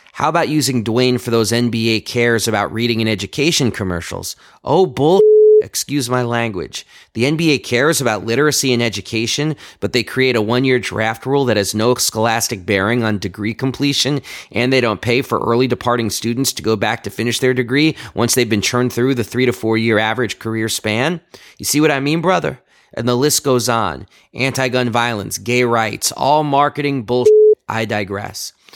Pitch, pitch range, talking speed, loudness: 120 Hz, 110-135 Hz, 185 wpm, -16 LUFS